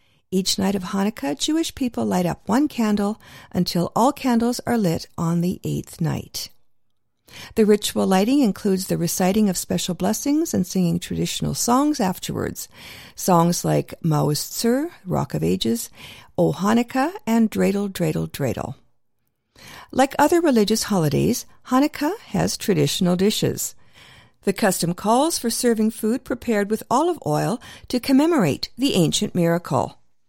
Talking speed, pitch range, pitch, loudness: 135 wpm, 175-250 Hz, 205 Hz, -21 LUFS